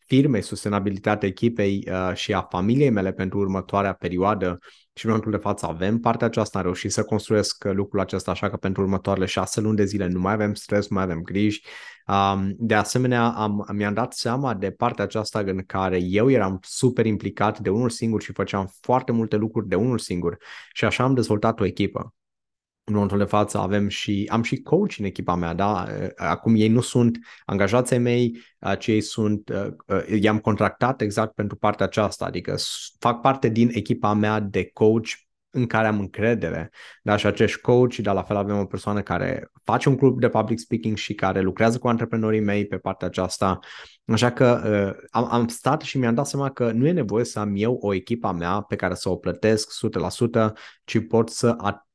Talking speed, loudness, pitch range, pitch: 195 wpm, -23 LUFS, 100-115 Hz, 105 Hz